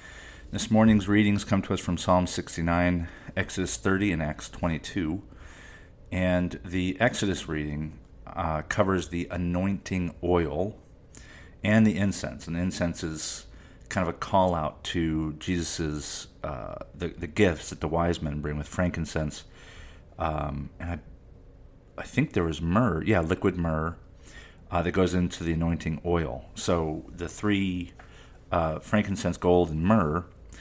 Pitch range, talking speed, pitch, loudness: 80-95 Hz, 145 wpm, 85 Hz, -28 LUFS